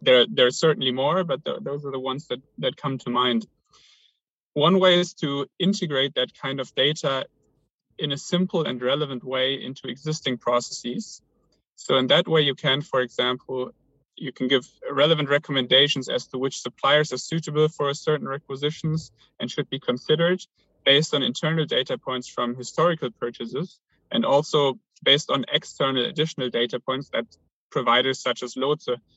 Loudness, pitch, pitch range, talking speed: -23 LUFS, 135 Hz, 125-155 Hz, 170 wpm